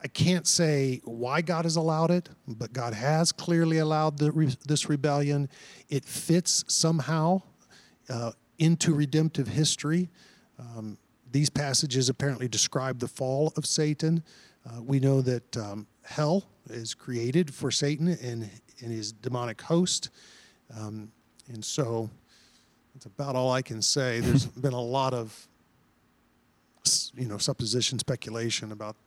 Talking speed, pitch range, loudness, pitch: 140 wpm, 120-155 Hz, -27 LUFS, 135 Hz